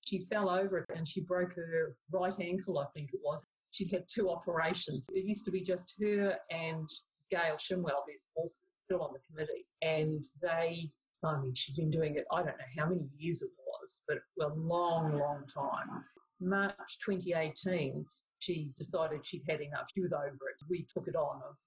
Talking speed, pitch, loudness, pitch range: 195 wpm, 170 Hz, -37 LUFS, 155-185 Hz